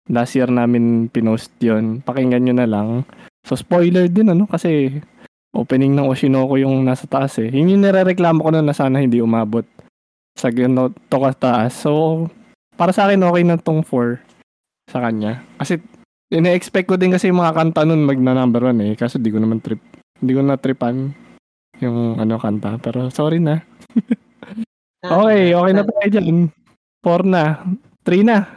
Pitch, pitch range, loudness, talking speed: 135 Hz, 120-175 Hz, -16 LUFS, 175 wpm